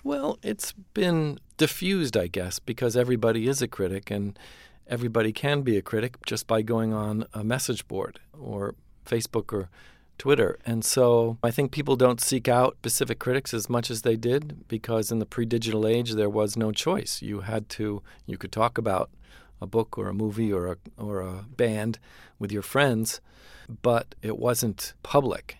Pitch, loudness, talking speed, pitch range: 115 Hz, -27 LUFS, 180 wpm, 105-125 Hz